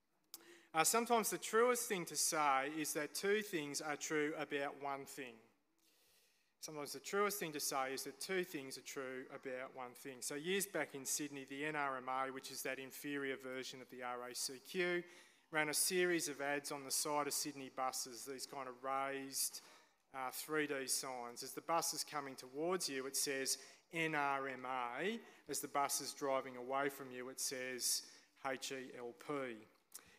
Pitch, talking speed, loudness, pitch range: 140 Hz, 170 wpm, -41 LUFS, 130-150 Hz